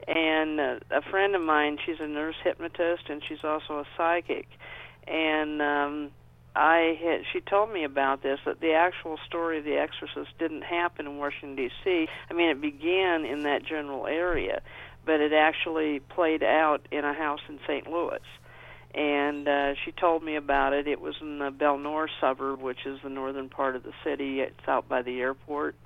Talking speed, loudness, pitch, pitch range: 185 wpm, -28 LUFS, 150 Hz, 140-165 Hz